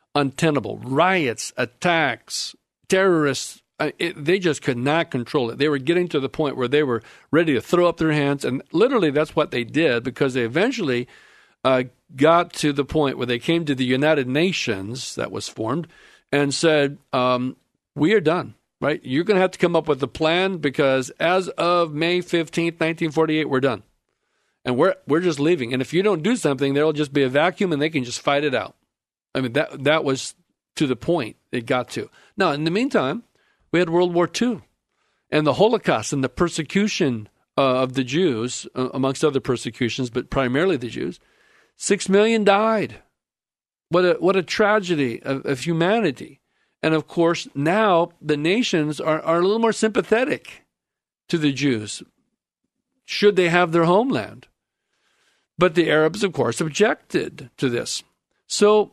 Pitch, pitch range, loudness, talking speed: 155 Hz, 135-180 Hz, -21 LUFS, 180 wpm